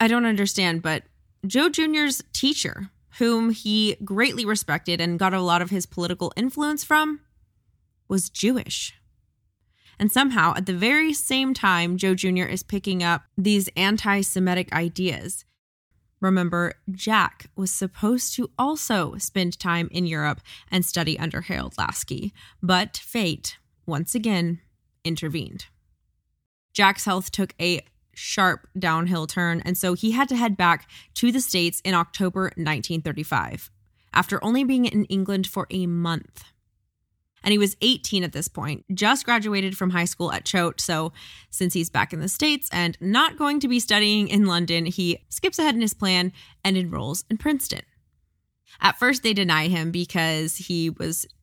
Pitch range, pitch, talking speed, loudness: 170-215 Hz, 185 Hz, 155 wpm, -23 LUFS